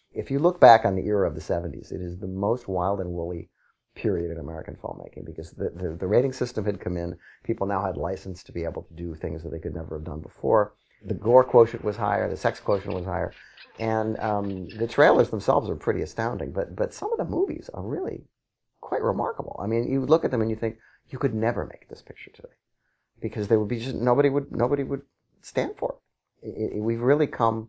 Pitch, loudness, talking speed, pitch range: 105 Hz, -26 LUFS, 235 wpm, 90-115 Hz